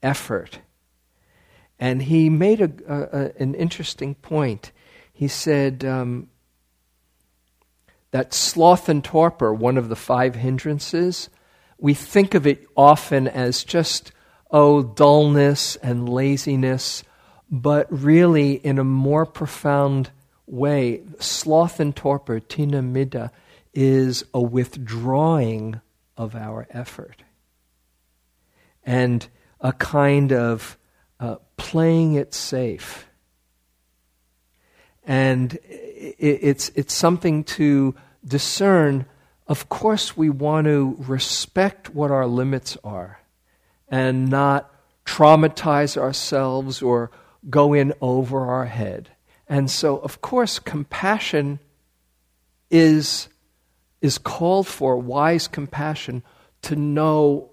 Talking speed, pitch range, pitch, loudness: 100 wpm, 120-150 Hz, 135 Hz, -20 LUFS